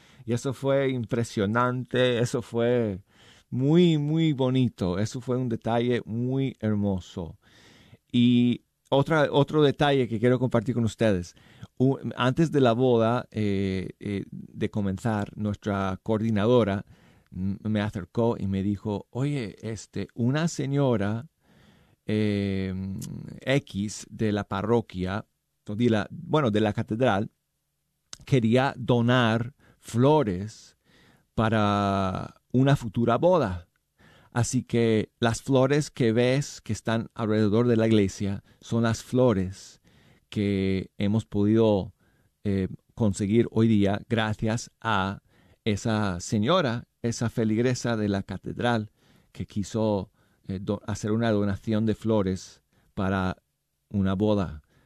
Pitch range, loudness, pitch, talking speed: 100-125 Hz, -26 LUFS, 110 Hz, 115 wpm